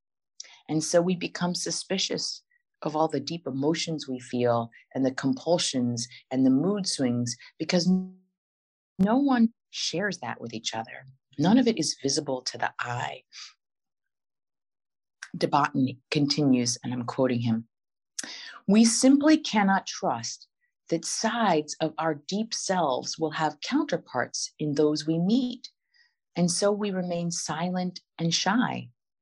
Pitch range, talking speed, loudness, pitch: 130-195 Hz, 135 wpm, -27 LUFS, 160 Hz